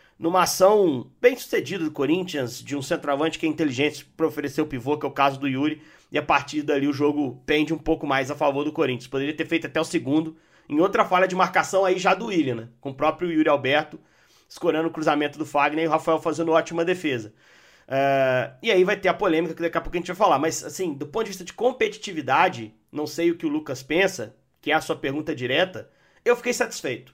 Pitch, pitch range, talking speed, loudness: 160 Hz, 145-175 Hz, 235 wpm, -23 LUFS